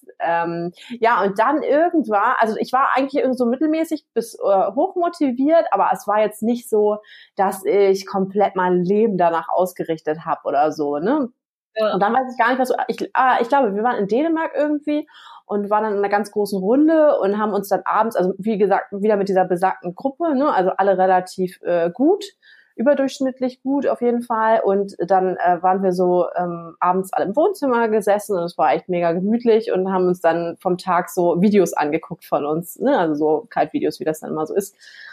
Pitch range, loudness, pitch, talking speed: 180-260 Hz, -19 LUFS, 205 Hz, 205 wpm